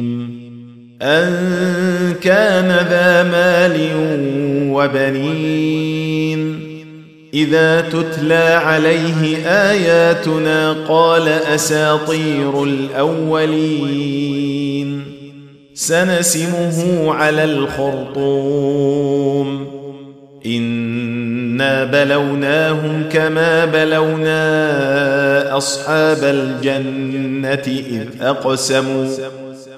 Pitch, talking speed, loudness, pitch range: 150 Hz, 45 wpm, -15 LUFS, 140-160 Hz